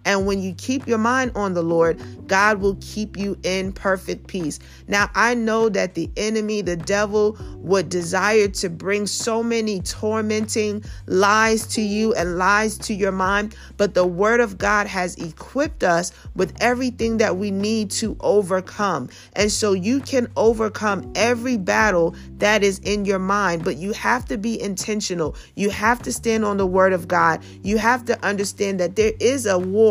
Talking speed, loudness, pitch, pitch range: 180 wpm, -20 LUFS, 205 Hz, 185-220 Hz